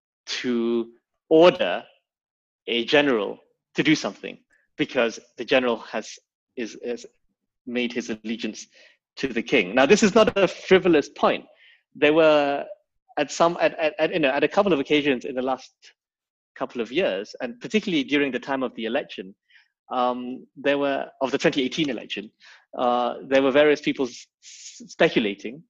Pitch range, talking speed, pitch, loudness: 125-160 Hz, 160 wpm, 140 Hz, -23 LUFS